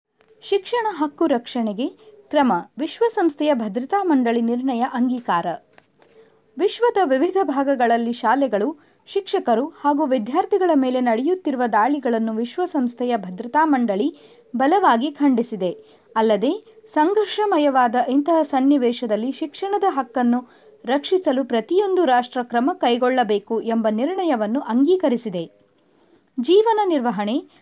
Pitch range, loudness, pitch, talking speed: 240-360 Hz, -20 LUFS, 275 Hz, 85 wpm